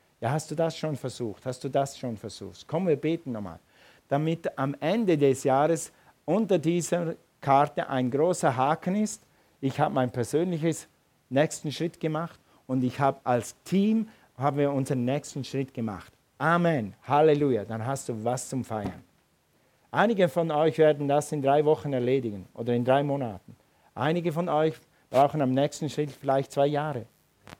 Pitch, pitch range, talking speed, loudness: 140 Hz, 130-155 Hz, 165 wpm, -27 LUFS